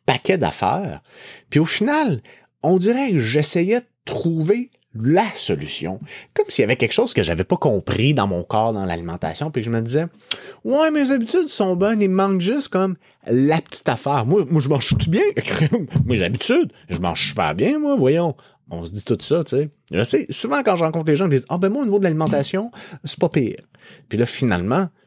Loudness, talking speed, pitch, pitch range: -19 LUFS, 210 wpm, 170 Hz, 140-205 Hz